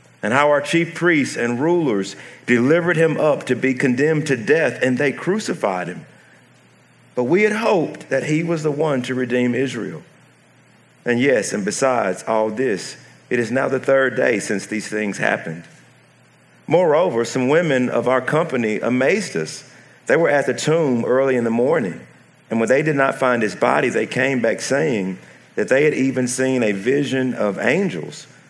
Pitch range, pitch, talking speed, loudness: 120-145 Hz, 130 Hz, 180 wpm, -19 LUFS